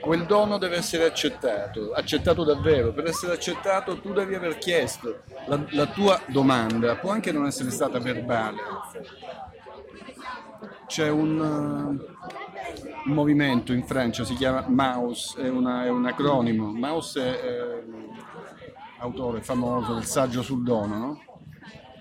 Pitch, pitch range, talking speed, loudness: 130 Hz, 125-155 Hz, 130 wpm, -25 LUFS